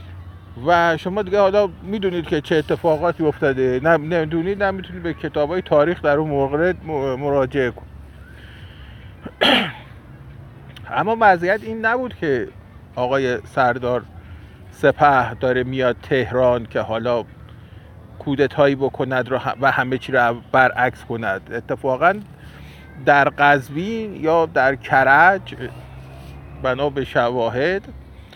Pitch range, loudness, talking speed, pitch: 110-165 Hz, -19 LUFS, 110 wpm, 135 Hz